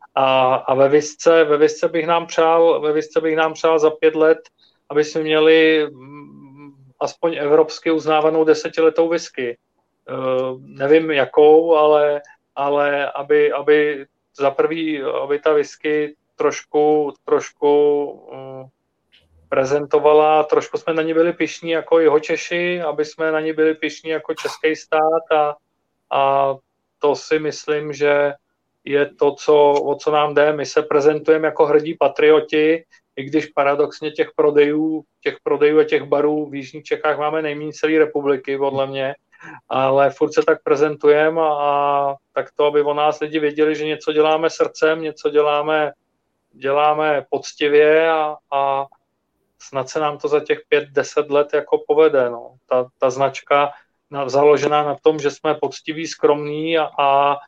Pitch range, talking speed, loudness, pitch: 145-160 Hz, 150 wpm, -18 LUFS, 150 Hz